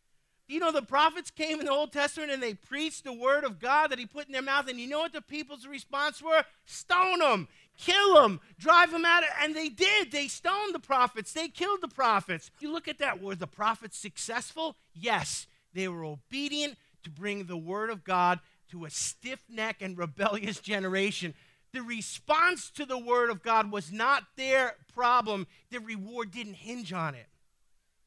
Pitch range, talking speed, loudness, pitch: 200-295 Hz, 190 wpm, -29 LUFS, 250 Hz